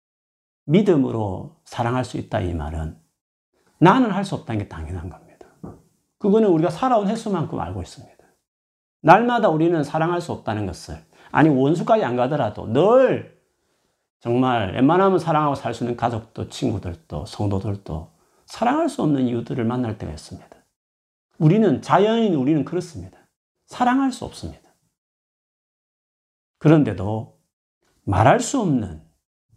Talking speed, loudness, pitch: 300 characters per minute, -20 LUFS, 125 Hz